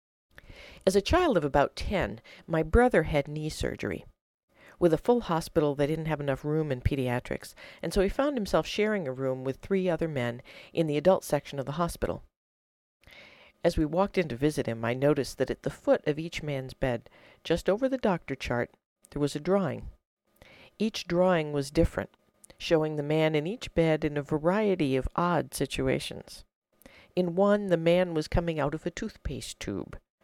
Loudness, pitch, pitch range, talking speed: -29 LUFS, 160 Hz, 135-185 Hz, 185 wpm